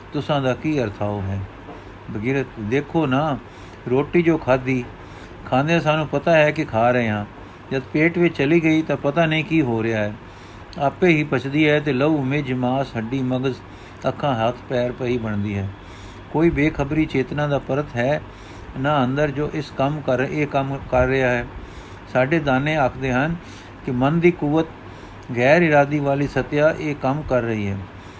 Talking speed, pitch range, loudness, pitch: 170 wpm, 110-150 Hz, -21 LUFS, 130 Hz